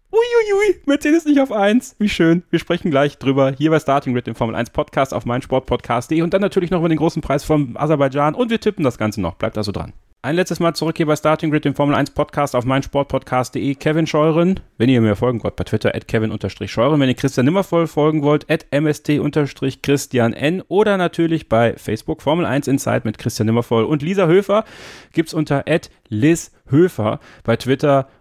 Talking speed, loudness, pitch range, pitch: 195 wpm, -18 LUFS, 125-165 Hz, 145 Hz